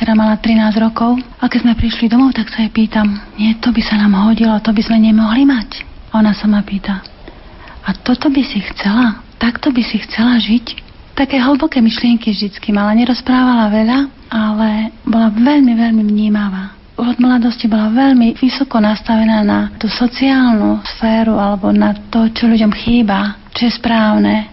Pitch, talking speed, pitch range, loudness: 225 Hz, 170 wpm, 215-240 Hz, -13 LUFS